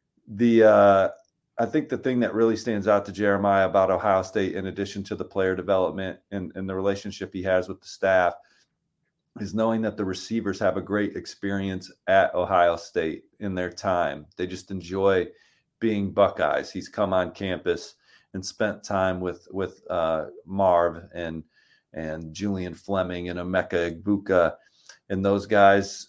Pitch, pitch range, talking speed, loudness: 95 Hz, 90-100 Hz, 165 wpm, -25 LUFS